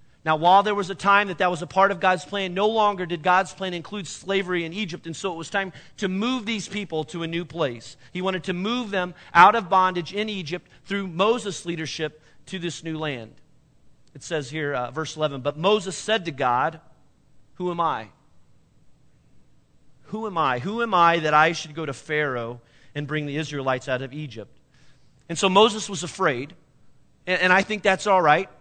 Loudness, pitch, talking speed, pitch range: -23 LUFS, 170 Hz, 205 wpm, 145-195 Hz